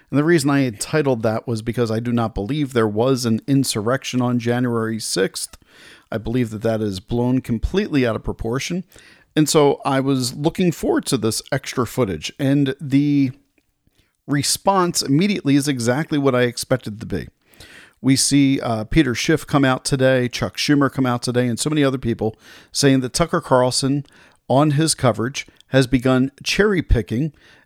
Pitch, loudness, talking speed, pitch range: 130 Hz, -19 LUFS, 175 wpm, 120-145 Hz